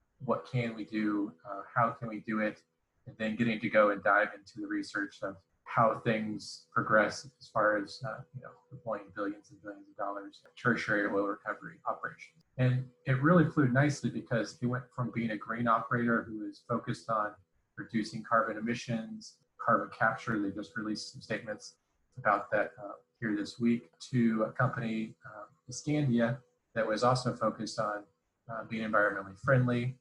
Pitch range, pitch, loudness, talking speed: 105-125 Hz, 115 Hz, -32 LUFS, 175 wpm